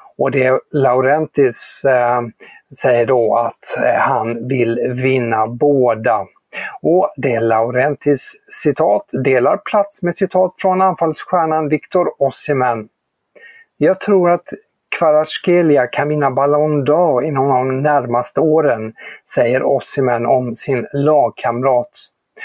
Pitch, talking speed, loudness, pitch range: 145 Hz, 105 wpm, -15 LUFS, 125-165 Hz